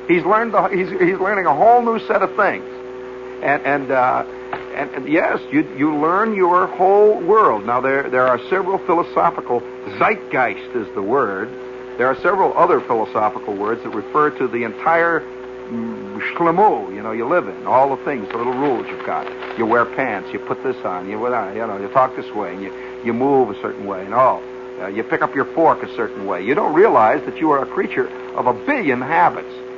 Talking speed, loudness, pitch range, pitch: 210 wpm, -18 LUFS, 125-185 Hz, 130 Hz